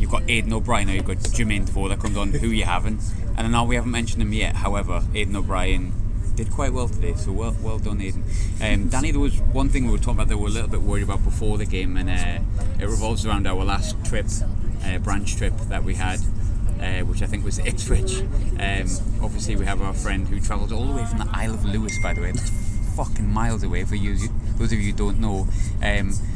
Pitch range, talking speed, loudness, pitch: 95-105 Hz, 250 wpm, -25 LUFS, 100 Hz